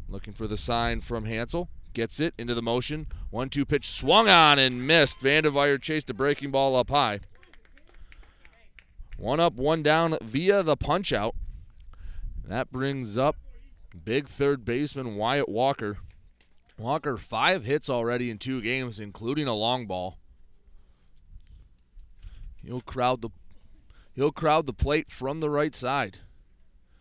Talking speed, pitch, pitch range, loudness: 140 wpm, 120 Hz, 90-140 Hz, -25 LUFS